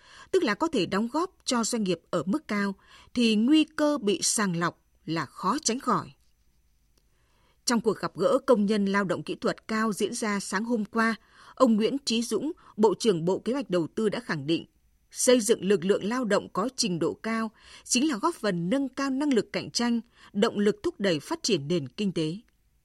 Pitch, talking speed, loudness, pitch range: 215 Hz, 215 wpm, -27 LUFS, 190-250 Hz